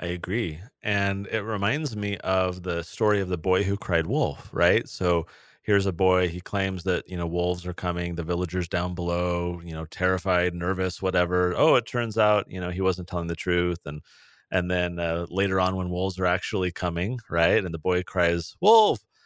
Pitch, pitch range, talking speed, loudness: 90 Hz, 90-95 Hz, 205 wpm, -25 LUFS